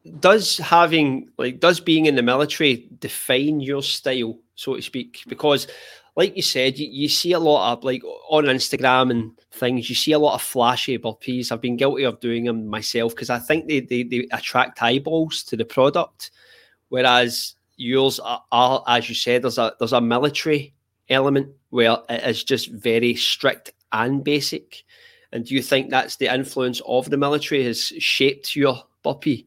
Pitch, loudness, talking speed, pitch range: 130 Hz, -20 LUFS, 180 wpm, 120-150 Hz